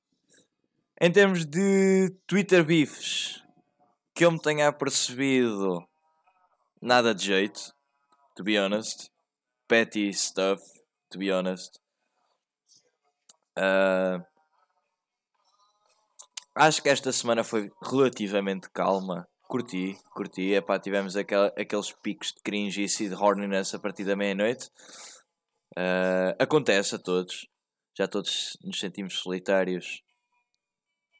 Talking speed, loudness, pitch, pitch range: 105 wpm, -26 LUFS, 105 Hz, 95-145 Hz